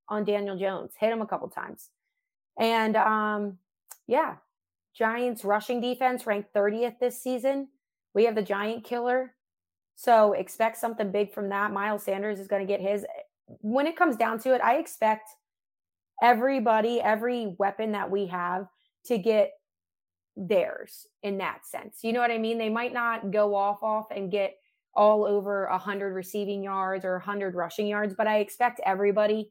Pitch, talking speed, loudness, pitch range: 210 Hz, 165 wpm, -27 LUFS, 200-235 Hz